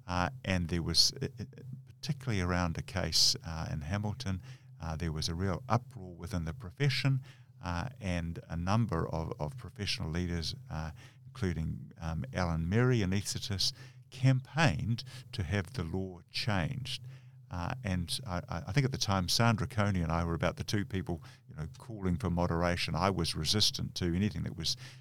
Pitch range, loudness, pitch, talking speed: 85-130 Hz, -33 LUFS, 100 Hz, 170 wpm